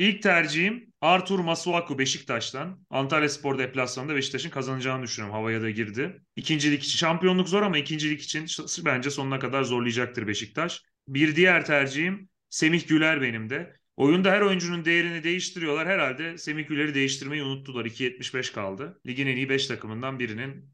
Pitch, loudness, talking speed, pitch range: 145 Hz, -26 LUFS, 150 wpm, 130-170 Hz